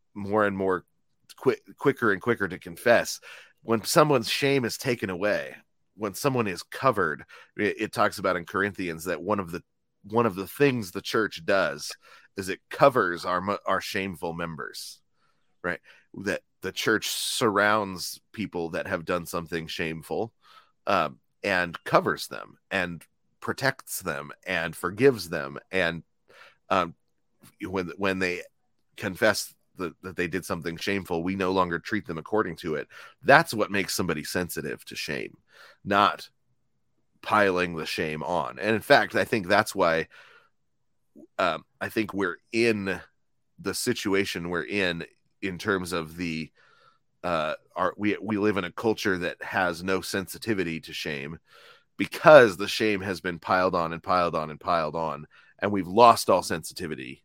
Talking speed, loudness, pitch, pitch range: 155 wpm, -26 LUFS, 95 Hz, 85-105 Hz